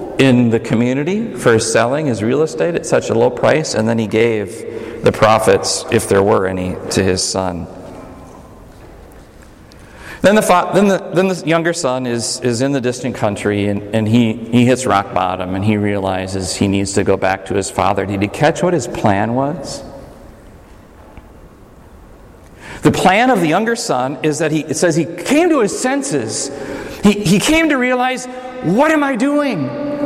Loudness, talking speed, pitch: -15 LUFS, 180 wpm, 125 Hz